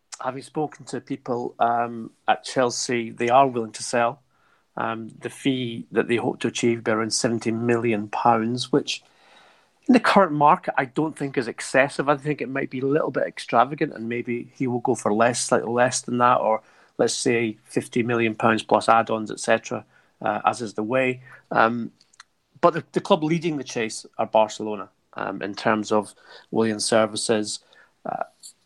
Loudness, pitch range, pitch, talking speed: -23 LUFS, 115-135 Hz, 120 Hz, 180 wpm